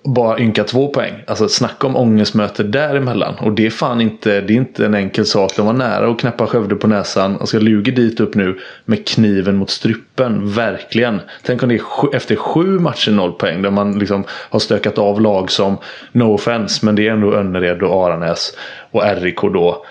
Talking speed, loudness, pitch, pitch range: 210 wpm, -15 LUFS, 105 Hz, 100-115 Hz